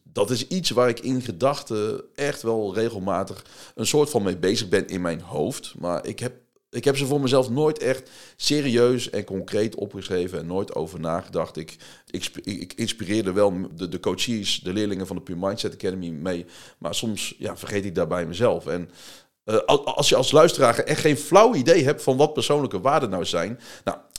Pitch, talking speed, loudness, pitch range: 110 Hz, 195 wpm, -23 LUFS, 100-130 Hz